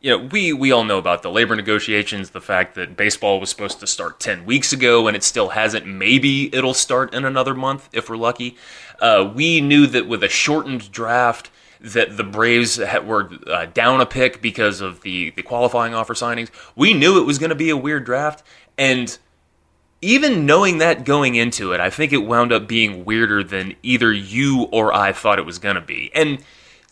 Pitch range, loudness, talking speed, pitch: 105-135 Hz, -17 LUFS, 210 wpm, 120 Hz